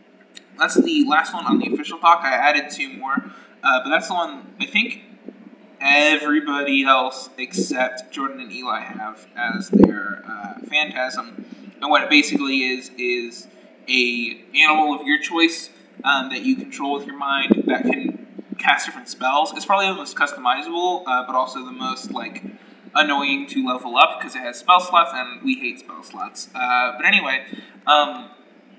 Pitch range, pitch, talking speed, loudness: 130-215 Hz, 150 Hz, 170 wpm, -19 LUFS